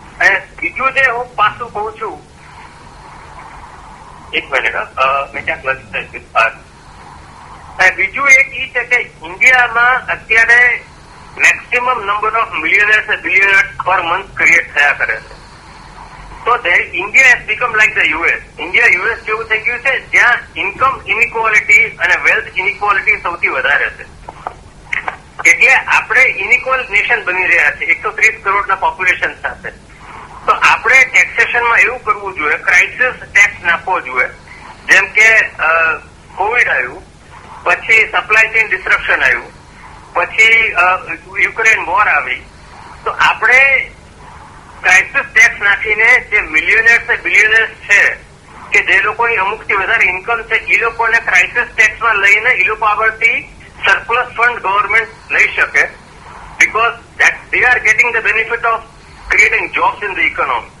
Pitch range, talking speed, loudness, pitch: 210-245 Hz, 120 wpm, -10 LUFS, 225 Hz